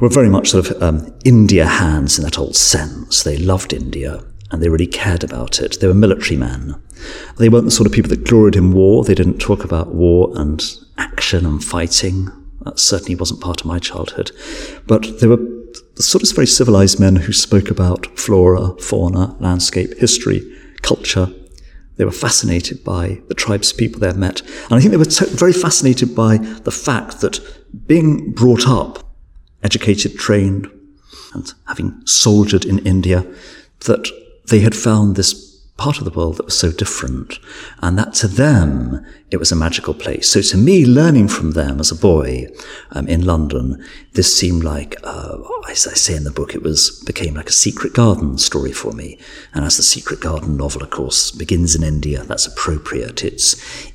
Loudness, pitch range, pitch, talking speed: -14 LUFS, 80-110 Hz, 95 Hz, 185 wpm